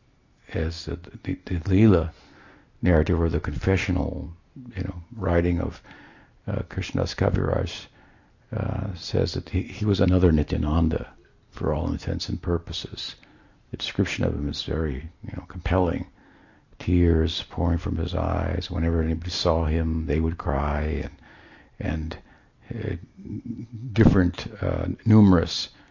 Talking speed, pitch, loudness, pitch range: 130 wpm, 90 Hz, -25 LUFS, 80-95 Hz